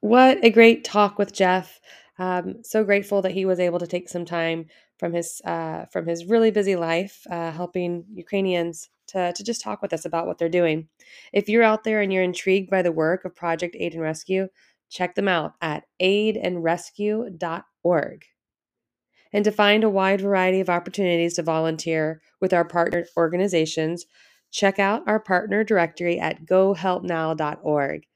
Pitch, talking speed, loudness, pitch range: 180 Hz, 170 wpm, -22 LUFS, 170-200 Hz